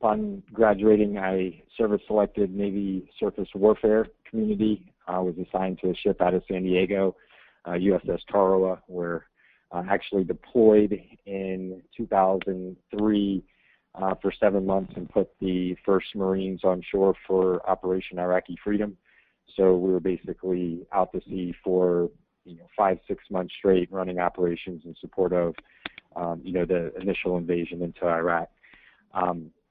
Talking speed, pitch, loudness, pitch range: 145 wpm, 95 Hz, -26 LUFS, 90-100 Hz